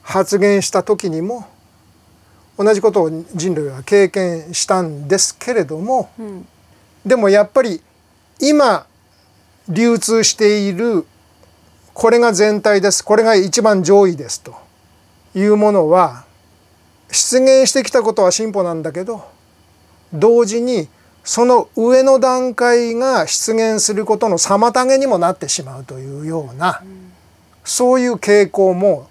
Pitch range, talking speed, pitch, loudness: 145-230 Hz, 240 characters per minute, 200 Hz, -14 LUFS